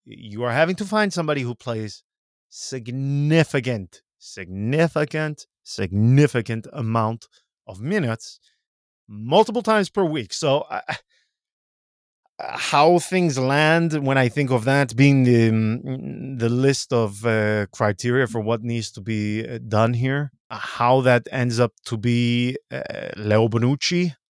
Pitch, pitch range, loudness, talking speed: 125 Hz, 115-145 Hz, -21 LUFS, 130 wpm